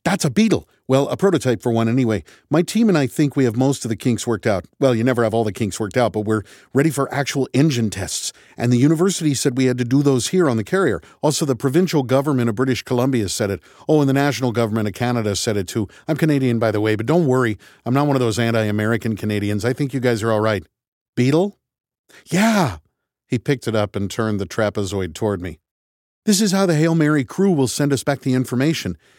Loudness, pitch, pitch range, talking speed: -19 LUFS, 125 Hz, 110-145 Hz, 245 wpm